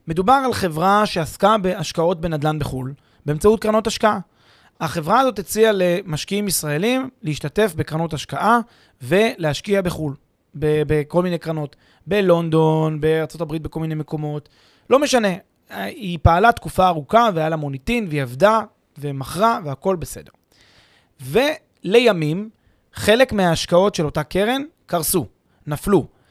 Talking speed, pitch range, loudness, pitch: 115 wpm, 150-205 Hz, -19 LUFS, 170 Hz